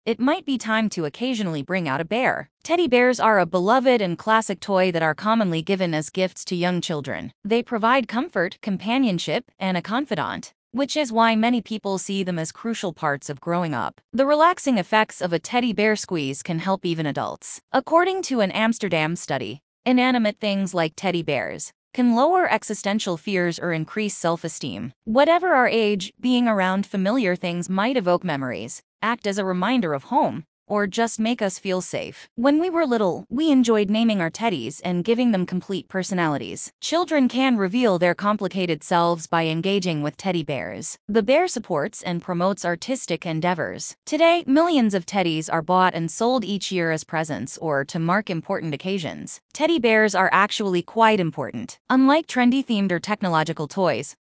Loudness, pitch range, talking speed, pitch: -22 LUFS, 175-235 Hz, 175 wpm, 195 Hz